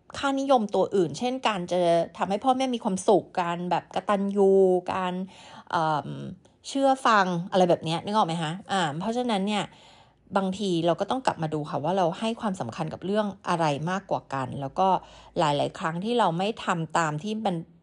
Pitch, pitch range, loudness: 190 Hz, 170-215 Hz, -26 LUFS